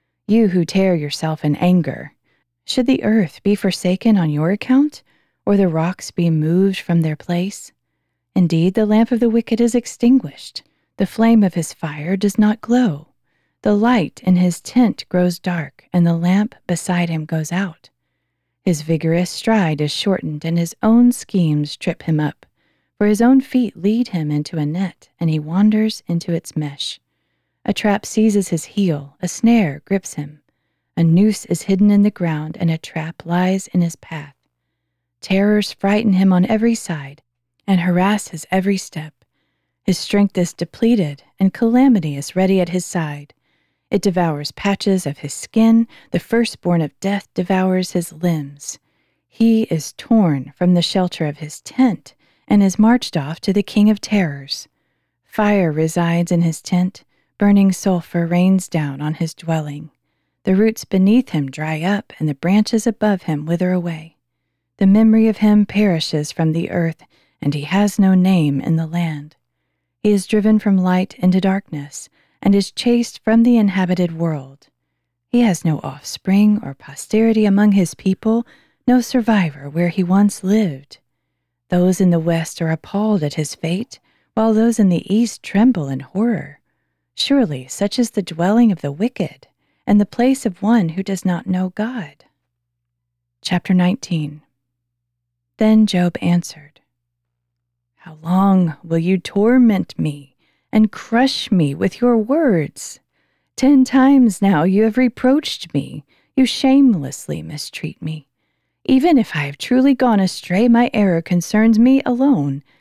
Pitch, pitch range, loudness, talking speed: 180 Hz, 155-215 Hz, -17 LUFS, 160 wpm